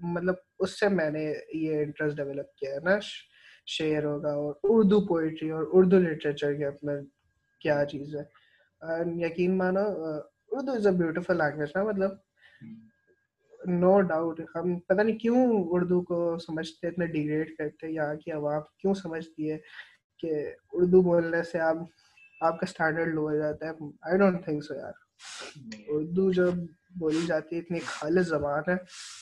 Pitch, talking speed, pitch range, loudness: 165 Hz, 155 wpm, 150-185 Hz, -28 LUFS